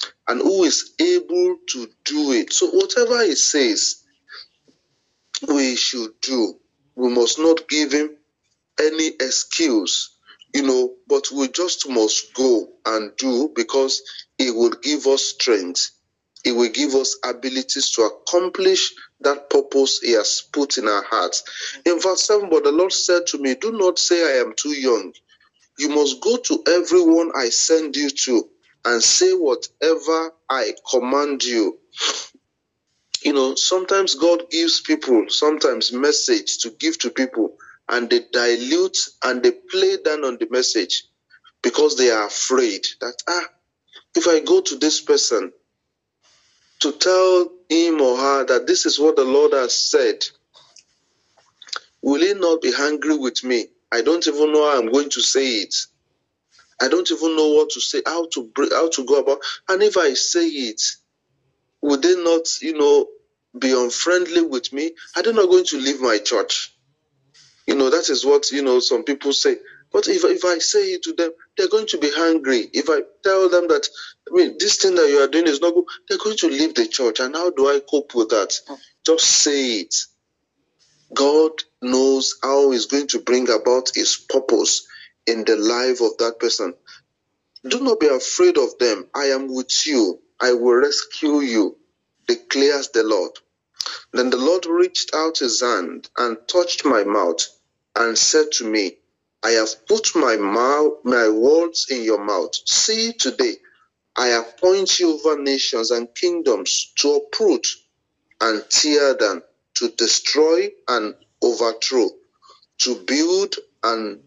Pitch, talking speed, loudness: 185 Hz, 165 wpm, -18 LUFS